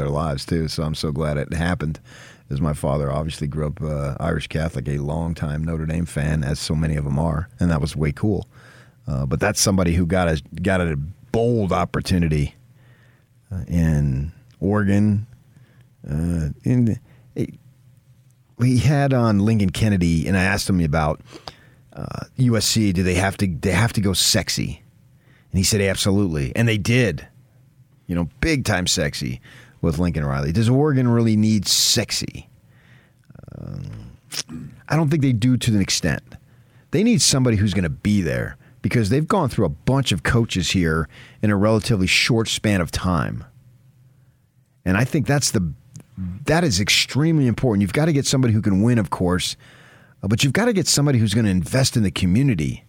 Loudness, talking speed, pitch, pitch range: -20 LUFS, 180 wpm, 105 Hz, 85-125 Hz